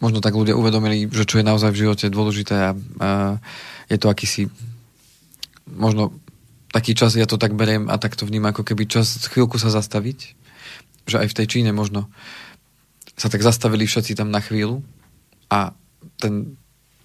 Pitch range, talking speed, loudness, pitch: 105-120 Hz, 165 wpm, -20 LUFS, 110 Hz